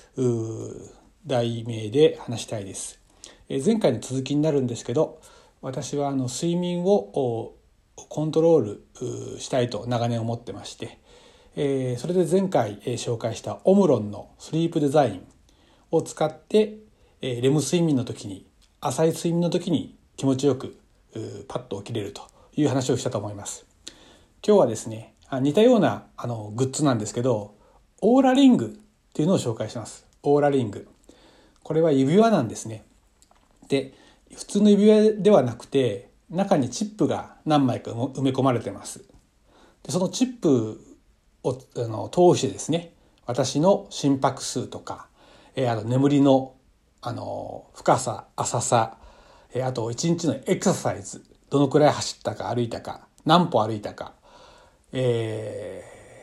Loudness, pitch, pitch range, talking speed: -24 LUFS, 135 Hz, 120-165 Hz, 280 characters per minute